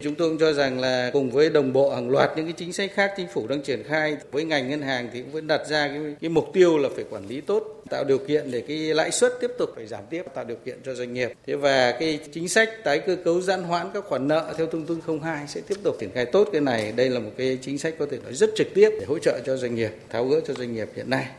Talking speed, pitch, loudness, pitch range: 305 wpm, 155 Hz, -24 LUFS, 140-195 Hz